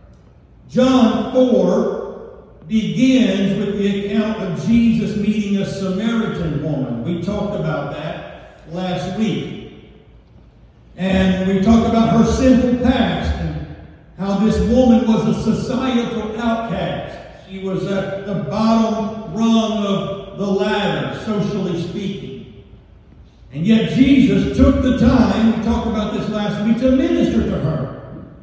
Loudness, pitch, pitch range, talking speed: -17 LUFS, 210 Hz, 195-230 Hz, 125 wpm